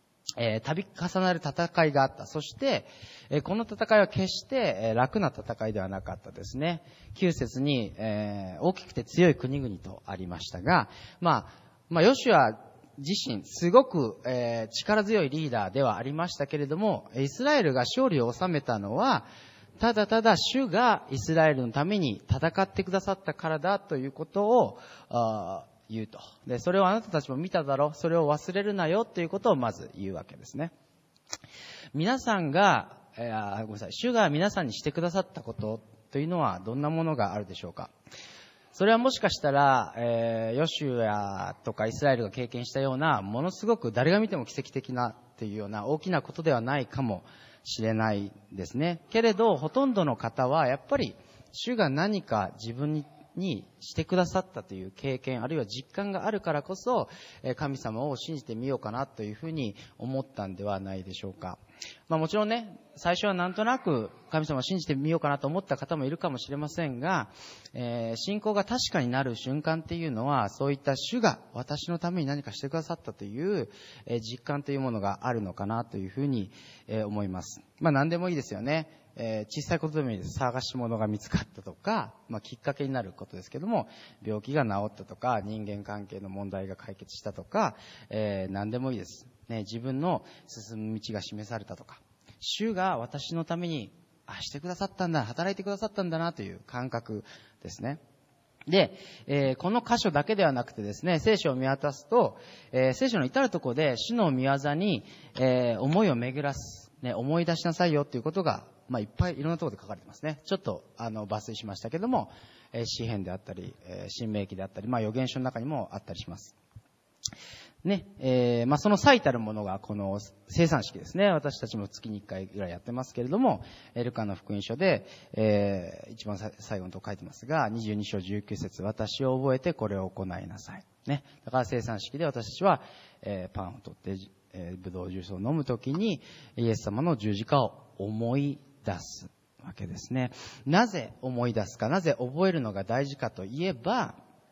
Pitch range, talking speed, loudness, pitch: 110-165 Hz, 370 characters per minute, -30 LUFS, 135 Hz